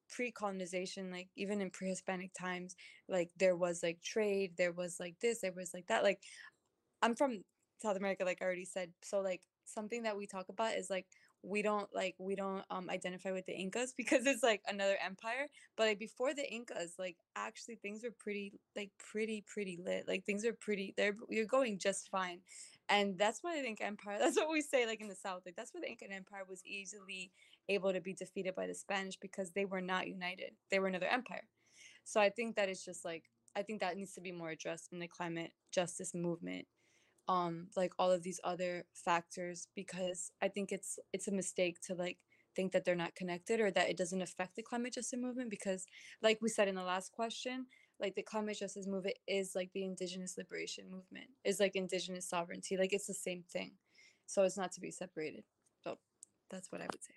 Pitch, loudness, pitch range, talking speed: 190 Hz, -39 LUFS, 180-210 Hz, 215 wpm